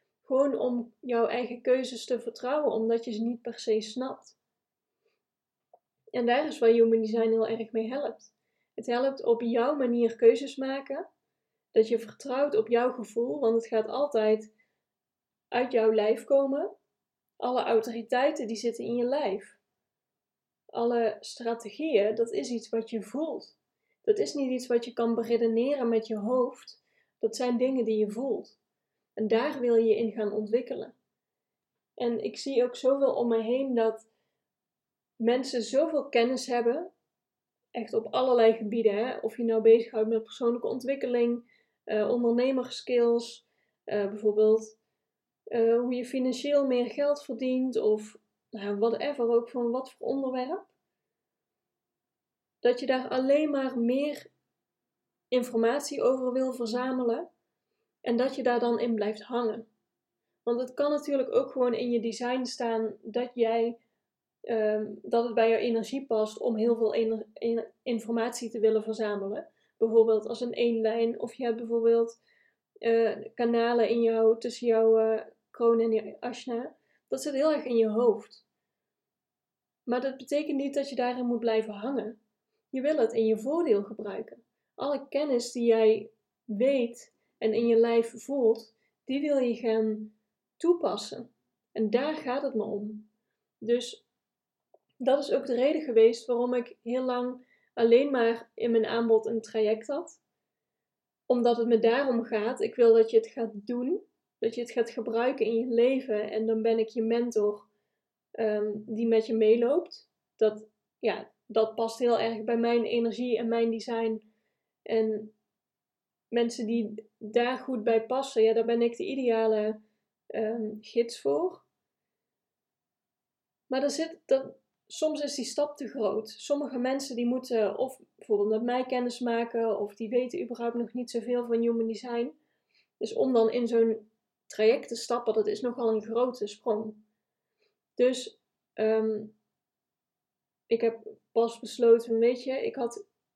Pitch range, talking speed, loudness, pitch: 225-255 Hz, 155 wpm, -28 LUFS, 235 Hz